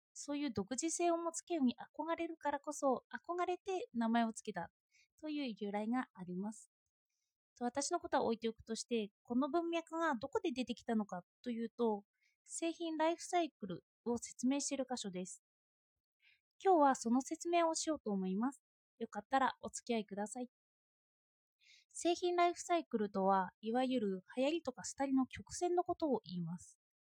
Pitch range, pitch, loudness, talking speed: 220-330 Hz, 260 Hz, -39 LUFS, 340 characters per minute